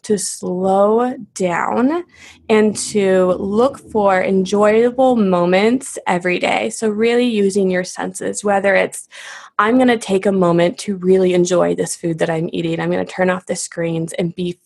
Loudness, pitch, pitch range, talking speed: -16 LUFS, 190 Hz, 180-215 Hz, 170 wpm